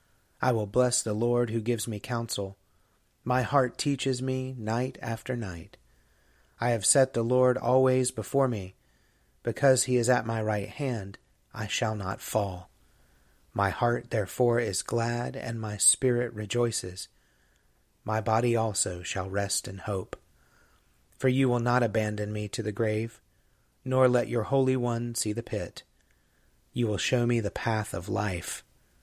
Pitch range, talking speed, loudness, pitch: 100-125 Hz, 155 wpm, -28 LUFS, 115 Hz